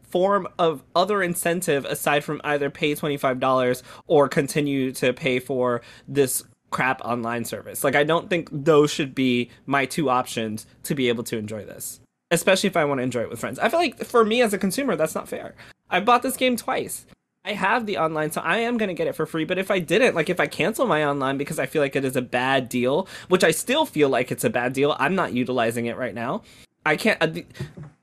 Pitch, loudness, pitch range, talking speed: 150 Hz, -23 LUFS, 125-180 Hz, 235 wpm